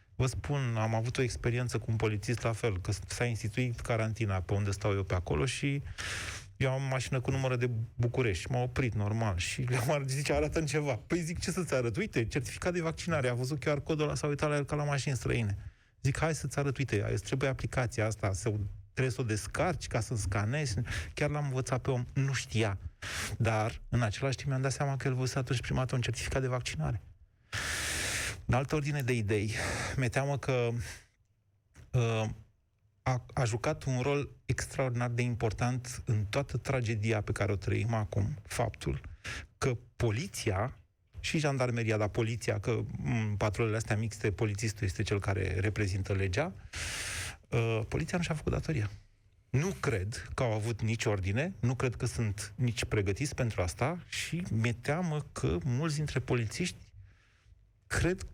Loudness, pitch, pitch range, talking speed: -33 LUFS, 115 Hz, 105-135 Hz, 175 wpm